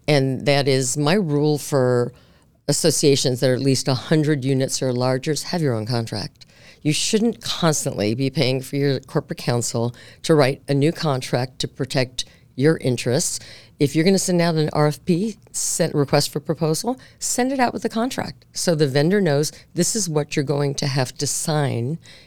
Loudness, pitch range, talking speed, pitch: -21 LUFS, 130-160 Hz, 185 wpm, 145 Hz